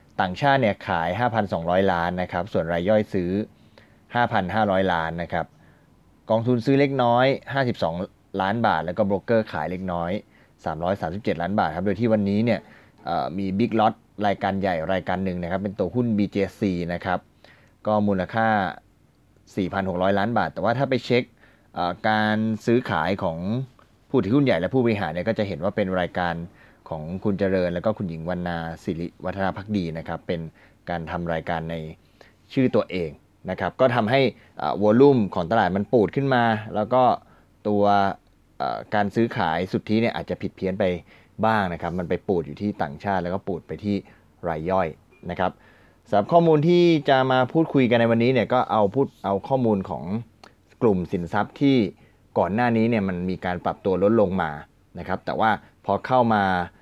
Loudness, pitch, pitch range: -23 LUFS, 100 Hz, 90-115 Hz